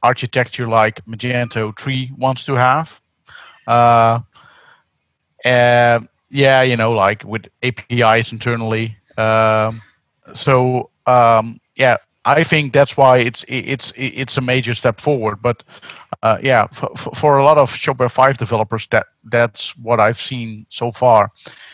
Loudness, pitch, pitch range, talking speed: -15 LUFS, 120 Hz, 115-130 Hz, 135 wpm